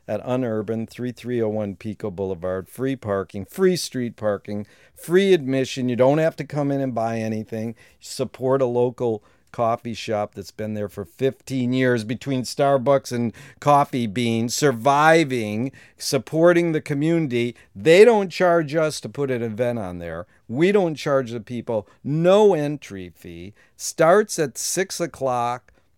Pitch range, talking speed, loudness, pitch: 110-145 Hz, 145 wpm, -21 LUFS, 125 Hz